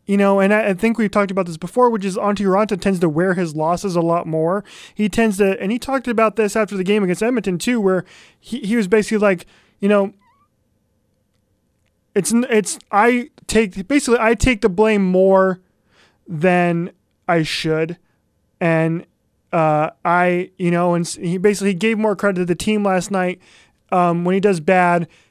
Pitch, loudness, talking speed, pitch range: 190 Hz, -18 LUFS, 185 wpm, 175-215 Hz